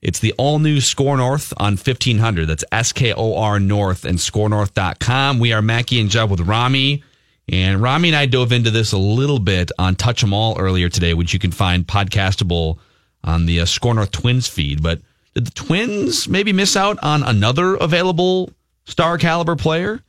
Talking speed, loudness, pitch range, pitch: 190 wpm, -17 LUFS, 95-140 Hz, 110 Hz